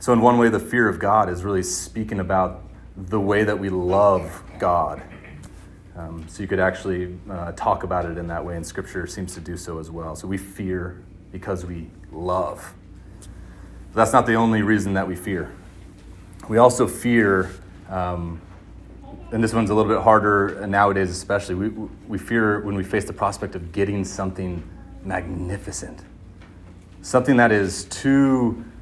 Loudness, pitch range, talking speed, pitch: -22 LUFS, 90-105 Hz, 170 wpm, 95 Hz